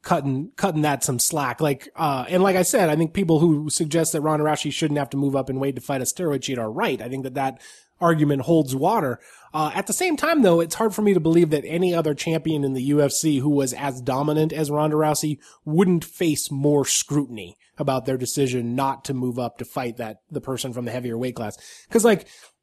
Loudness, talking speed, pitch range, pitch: -22 LUFS, 235 wpm, 135-165 Hz, 145 Hz